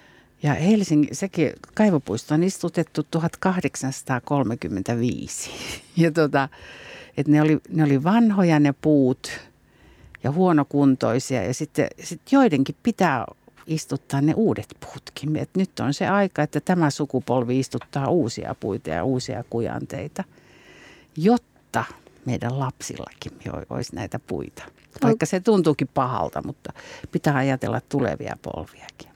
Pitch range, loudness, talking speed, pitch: 130-170 Hz, -23 LUFS, 115 wpm, 145 Hz